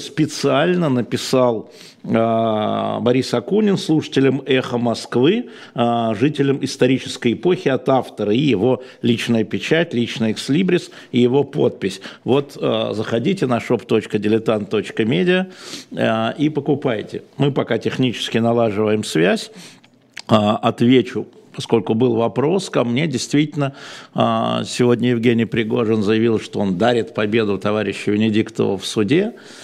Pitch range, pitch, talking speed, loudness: 110-140 Hz, 120 Hz, 115 wpm, -18 LUFS